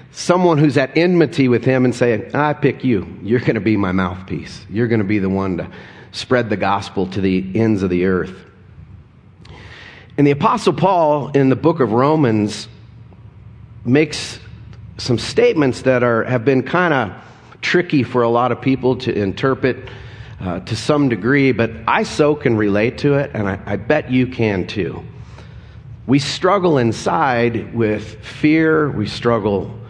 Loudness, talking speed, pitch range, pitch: -17 LUFS, 170 wpm, 110-140 Hz, 120 Hz